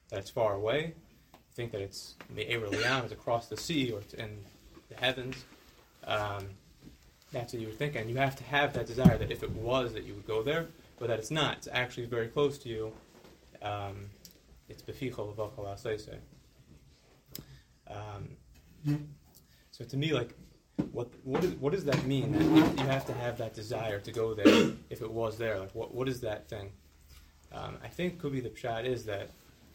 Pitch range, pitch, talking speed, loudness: 105-135 Hz, 115 Hz, 180 wpm, -33 LUFS